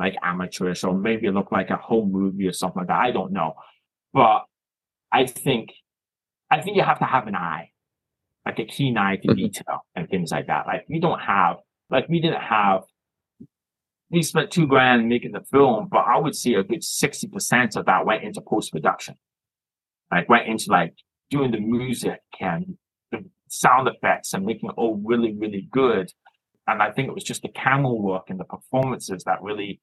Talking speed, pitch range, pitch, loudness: 195 wpm, 100-130 Hz, 115 Hz, -22 LUFS